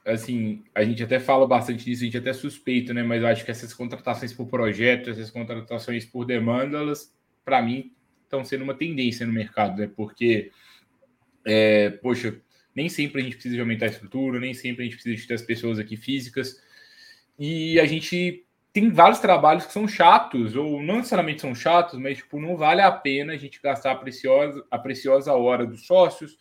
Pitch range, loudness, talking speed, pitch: 115-145 Hz, -23 LUFS, 200 wpm, 125 Hz